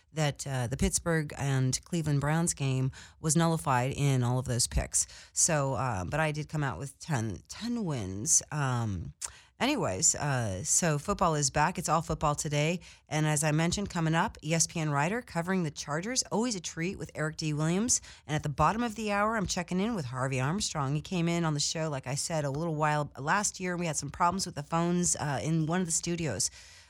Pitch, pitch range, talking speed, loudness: 155 Hz, 135-170 Hz, 210 wpm, -30 LUFS